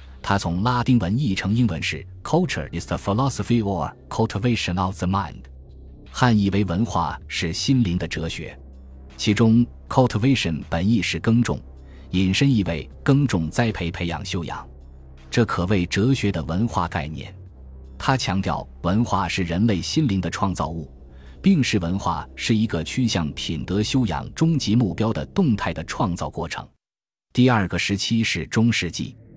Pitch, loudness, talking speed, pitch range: 95 Hz, -22 LUFS, 315 characters per minute, 80-115 Hz